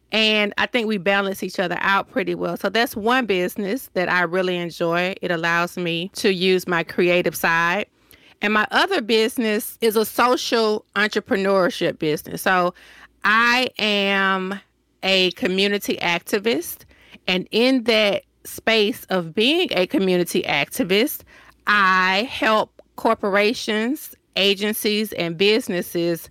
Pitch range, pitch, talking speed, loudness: 180-225 Hz, 200 Hz, 130 wpm, -20 LUFS